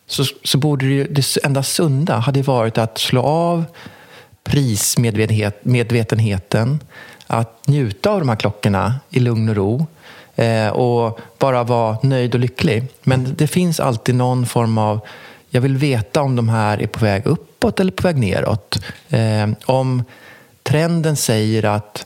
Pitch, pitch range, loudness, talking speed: 125 Hz, 110-140 Hz, -17 LUFS, 155 wpm